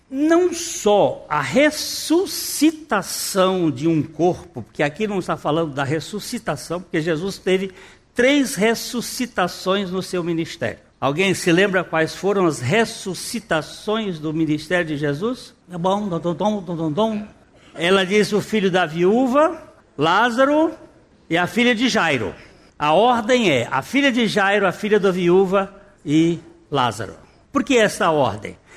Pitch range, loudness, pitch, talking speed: 165-235 Hz, -19 LUFS, 195 Hz, 130 wpm